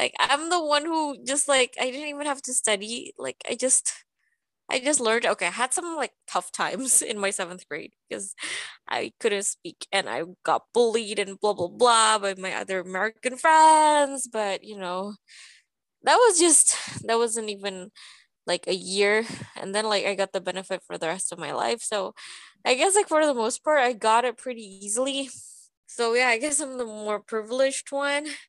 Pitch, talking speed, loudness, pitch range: 225 Hz, 200 wpm, -24 LUFS, 195-275 Hz